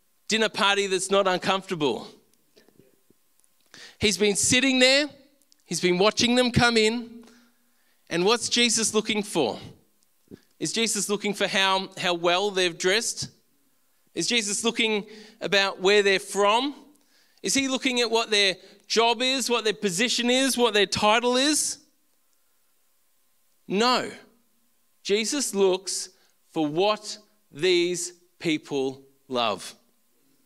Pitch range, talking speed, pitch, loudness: 190-245 Hz, 120 wpm, 215 Hz, -23 LUFS